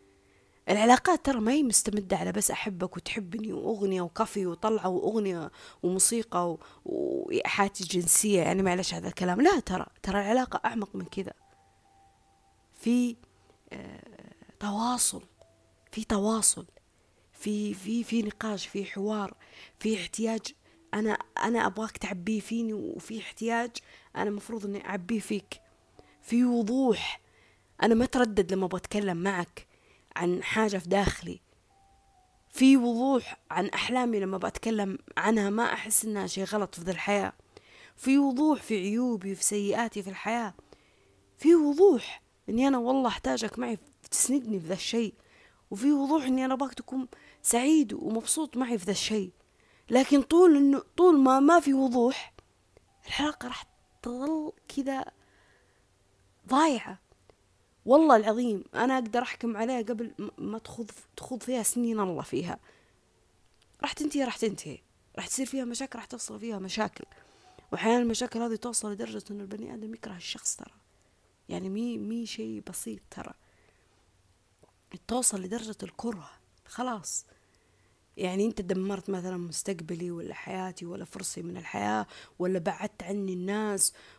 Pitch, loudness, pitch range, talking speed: 215 Hz, -28 LUFS, 185-245 Hz, 135 wpm